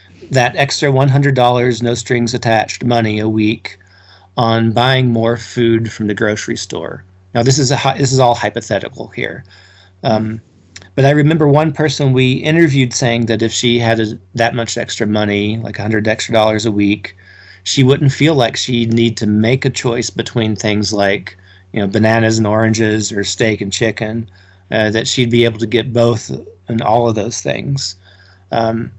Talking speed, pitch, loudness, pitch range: 185 wpm, 115 Hz, -14 LUFS, 105-125 Hz